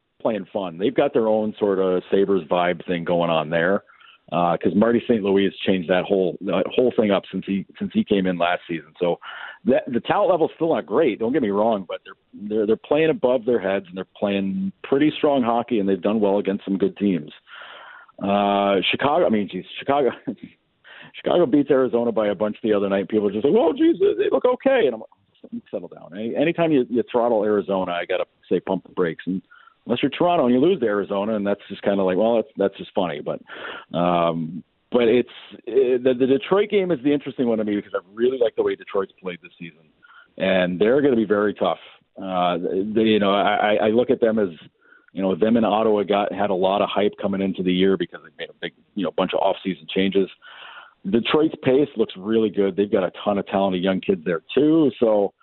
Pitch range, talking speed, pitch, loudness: 95-130 Hz, 235 wpm, 105 Hz, -21 LUFS